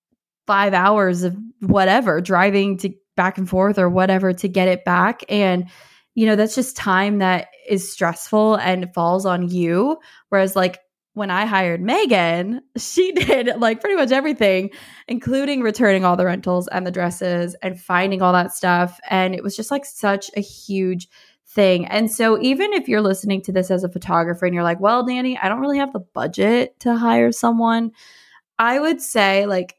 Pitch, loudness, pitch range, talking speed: 195 Hz, -18 LUFS, 180-225 Hz, 185 wpm